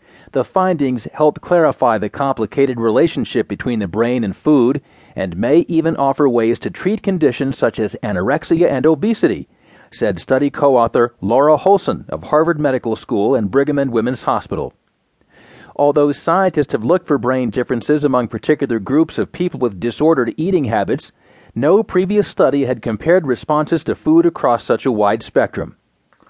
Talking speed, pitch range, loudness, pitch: 155 wpm, 125-170 Hz, -16 LUFS, 145 Hz